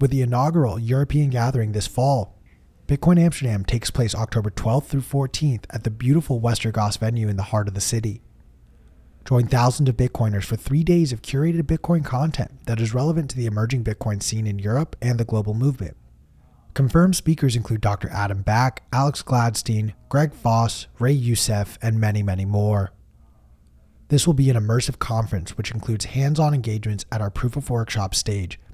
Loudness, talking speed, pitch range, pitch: -22 LUFS, 175 wpm, 105-135 Hz, 115 Hz